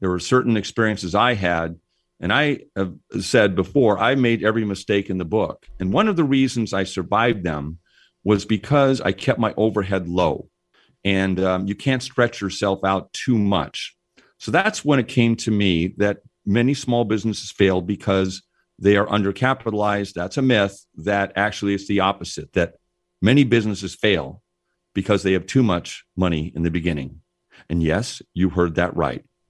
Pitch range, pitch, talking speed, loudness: 95-110 Hz, 100 Hz, 175 wpm, -21 LUFS